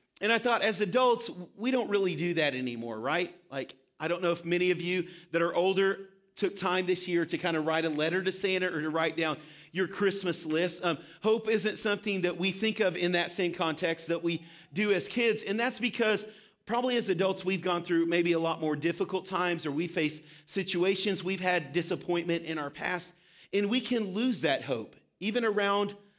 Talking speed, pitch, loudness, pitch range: 210 wpm, 180 Hz, -30 LUFS, 170-200 Hz